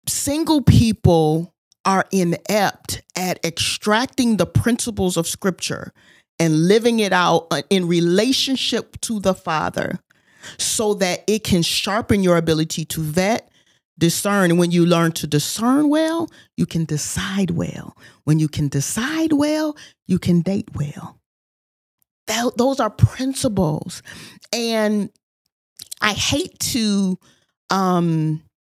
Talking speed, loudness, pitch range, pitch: 120 wpm, -19 LUFS, 165-225 Hz, 185 Hz